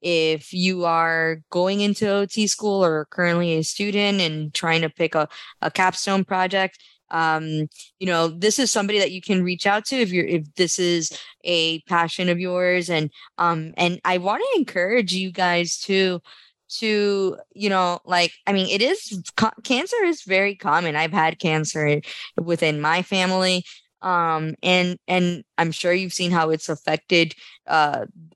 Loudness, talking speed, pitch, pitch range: -21 LUFS, 170 wpm, 180 Hz, 165-195 Hz